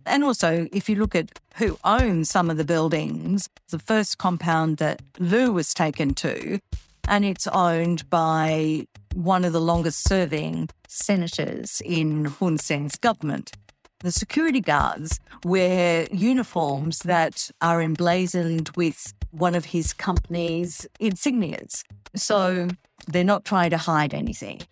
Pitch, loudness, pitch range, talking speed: 170 Hz, -23 LUFS, 160-190 Hz, 135 wpm